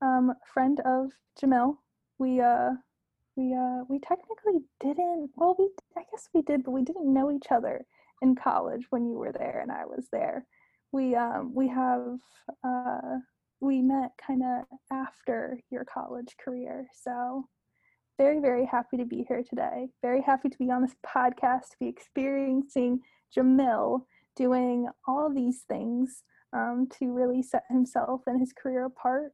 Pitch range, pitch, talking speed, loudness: 250-275 Hz, 260 Hz, 160 wpm, -29 LUFS